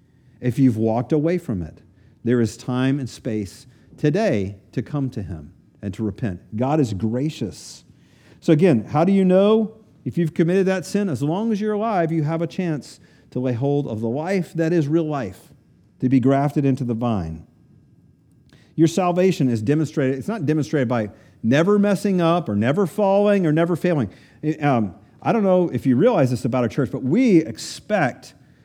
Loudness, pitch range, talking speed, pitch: -21 LUFS, 120-170 Hz, 185 wpm, 140 Hz